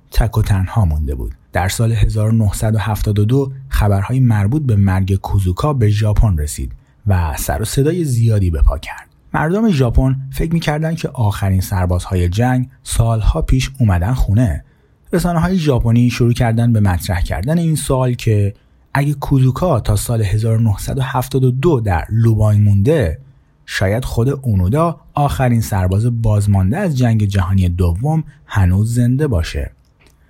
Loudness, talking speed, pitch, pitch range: -16 LUFS, 135 wpm, 110 Hz, 95-130 Hz